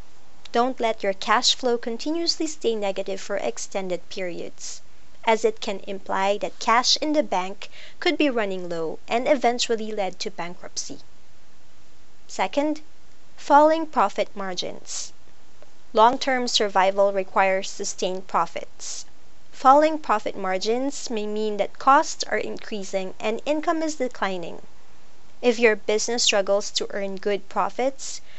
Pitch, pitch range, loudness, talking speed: 220 Hz, 195-260 Hz, -23 LUFS, 125 wpm